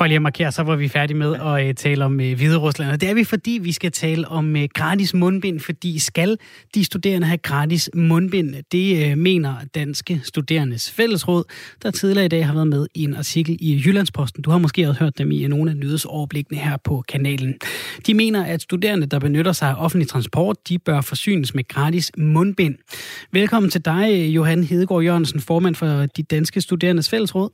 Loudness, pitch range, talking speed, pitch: -19 LUFS, 145-180 Hz, 190 wpm, 160 Hz